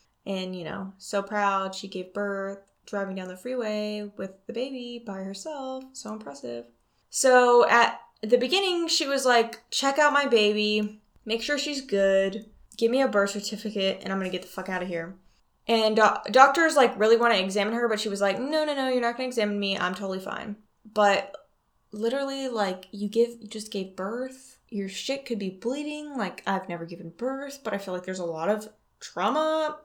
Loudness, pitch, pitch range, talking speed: -26 LUFS, 215 Hz, 195-250 Hz, 205 wpm